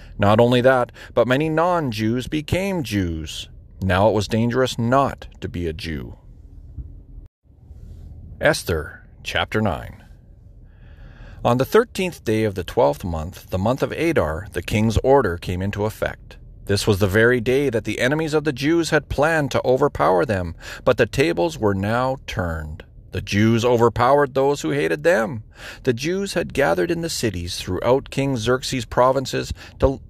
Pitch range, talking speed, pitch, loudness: 95-135 Hz, 160 wpm, 115 Hz, -20 LUFS